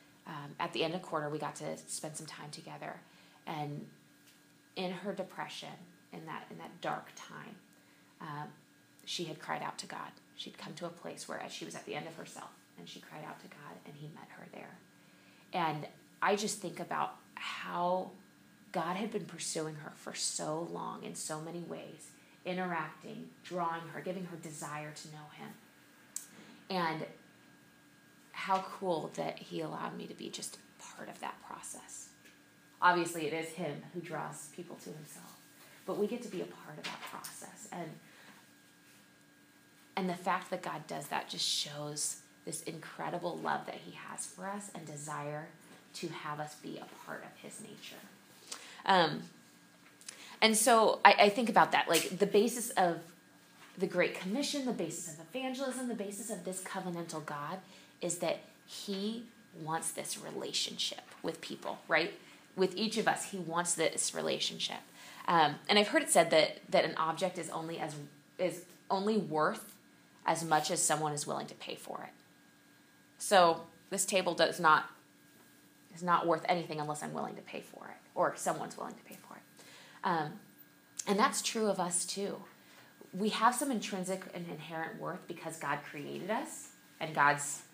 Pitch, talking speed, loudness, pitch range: 175 Hz, 175 wpm, -35 LUFS, 155-195 Hz